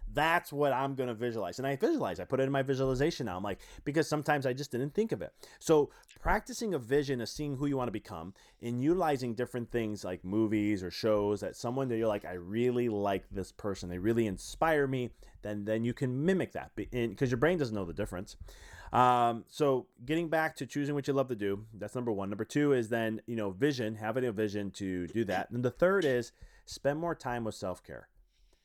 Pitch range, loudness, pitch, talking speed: 105-140 Hz, -33 LUFS, 120 Hz, 225 wpm